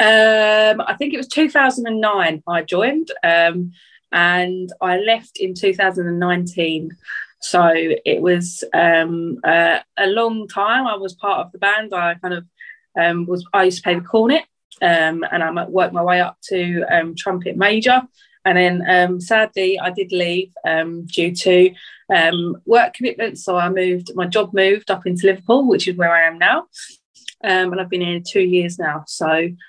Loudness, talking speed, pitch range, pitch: -17 LUFS, 175 wpm, 175-210 Hz, 185 Hz